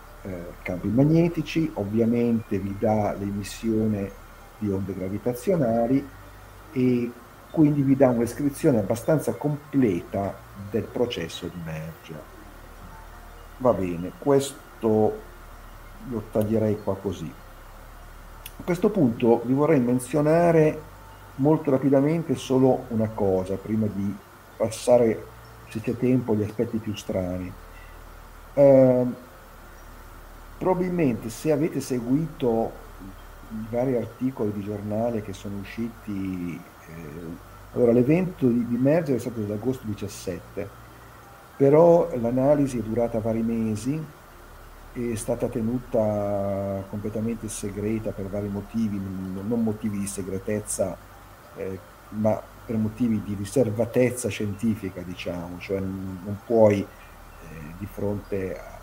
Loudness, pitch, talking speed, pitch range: -25 LUFS, 110 Hz, 110 wpm, 100-125 Hz